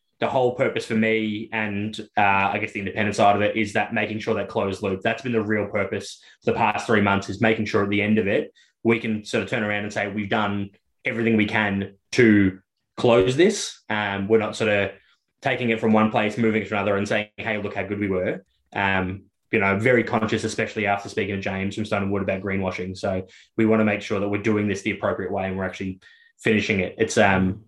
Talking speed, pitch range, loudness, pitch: 240 wpm, 100-110 Hz, -23 LUFS, 105 Hz